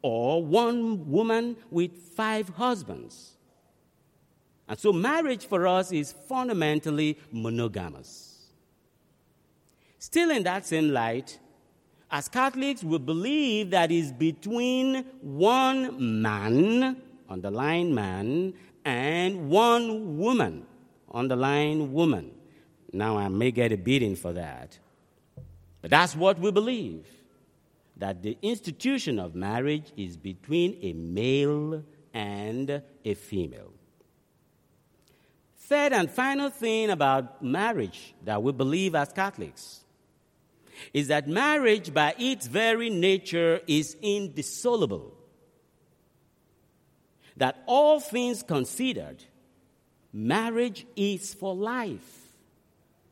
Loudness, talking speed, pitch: -27 LUFS, 105 wpm, 170 Hz